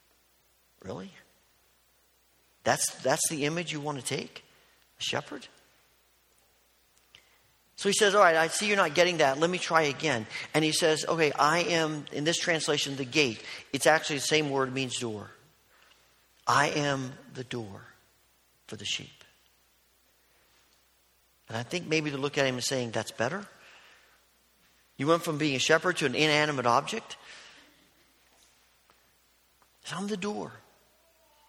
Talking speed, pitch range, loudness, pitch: 145 wpm, 120-160 Hz, -28 LUFS, 145 Hz